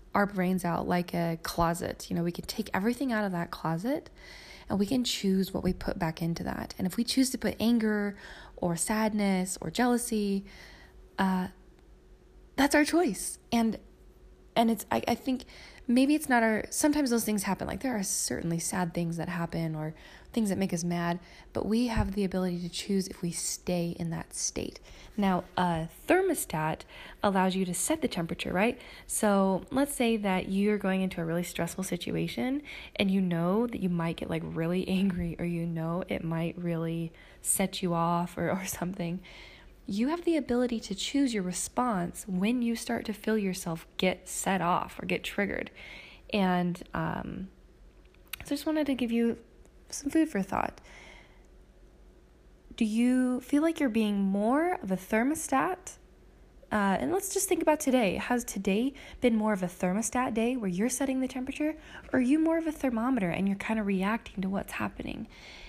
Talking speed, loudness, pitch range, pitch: 185 wpm, -30 LUFS, 180-245 Hz, 200 Hz